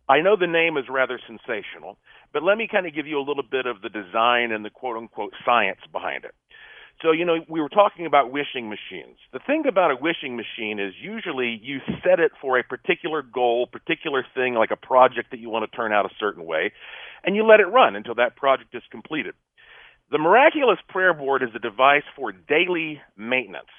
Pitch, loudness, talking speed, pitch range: 135 Hz, -22 LUFS, 215 wpm, 120-180 Hz